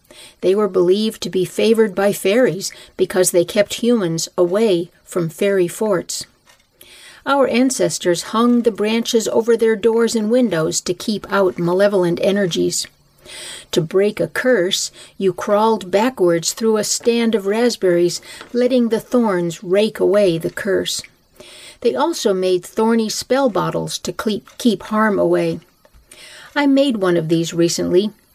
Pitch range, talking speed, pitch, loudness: 180-230 Hz, 140 wpm, 200 Hz, -17 LUFS